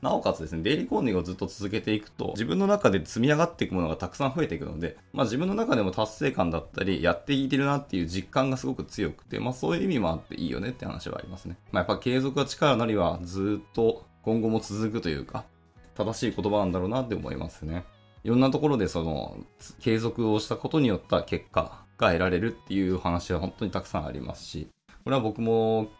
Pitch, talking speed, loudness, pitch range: 105 Hz, 480 characters per minute, -28 LUFS, 90-115 Hz